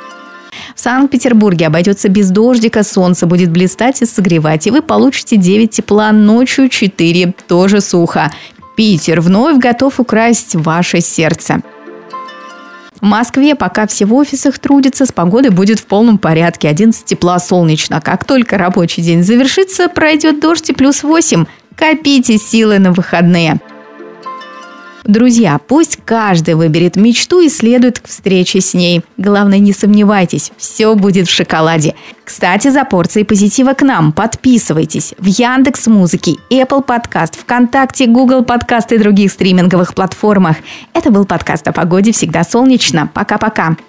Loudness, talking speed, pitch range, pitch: -9 LUFS, 135 wpm, 180-250 Hz, 210 Hz